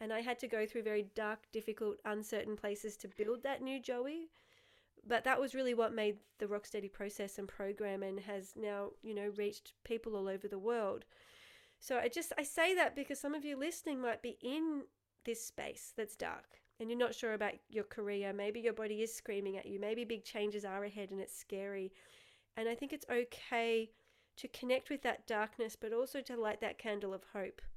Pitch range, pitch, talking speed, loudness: 205-250 Hz, 220 Hz, 205 wpm, -40 LUFS